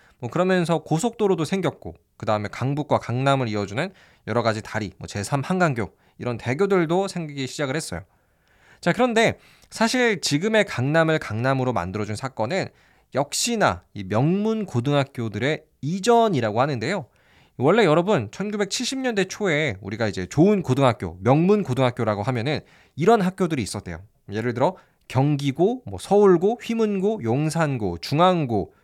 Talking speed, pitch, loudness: 325 characters per minute, 140 Hz, -23 LUFS